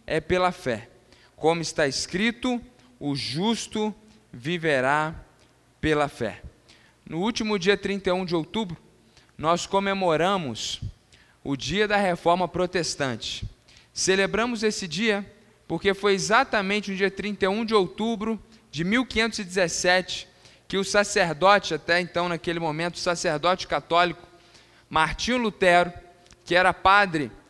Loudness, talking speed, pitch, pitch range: -24 LUFS, 115 wpm, 175 Hz, 155-200 Hz